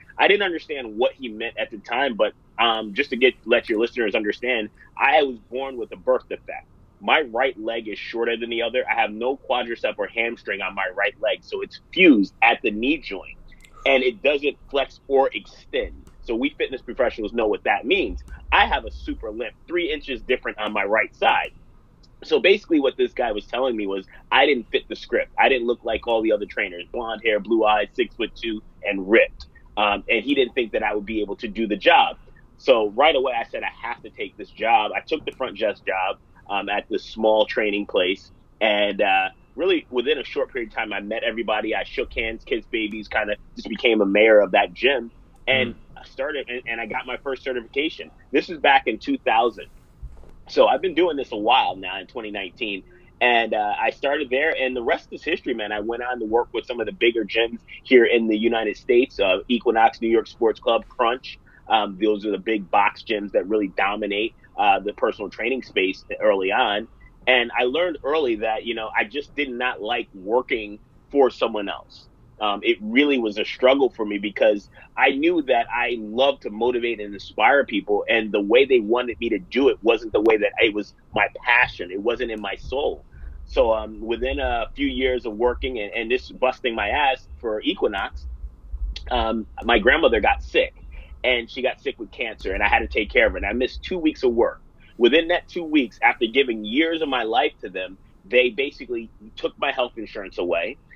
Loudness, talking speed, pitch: -22 LUFS, 215 wpm, 125 Hz